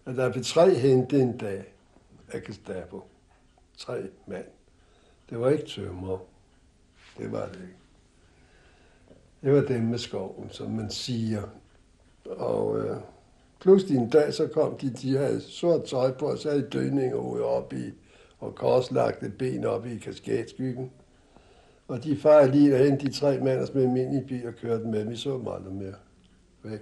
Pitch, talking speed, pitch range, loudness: 125 Hz, 170 wpm, 95-140 Hz, -26 LUFS